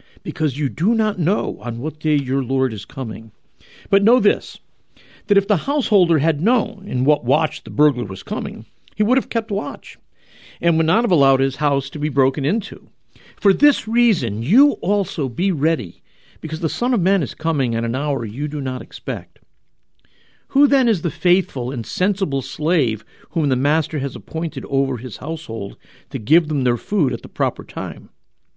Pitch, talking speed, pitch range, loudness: 155 Hz, 190 wpm, 135-200 Hz, -20 LUFS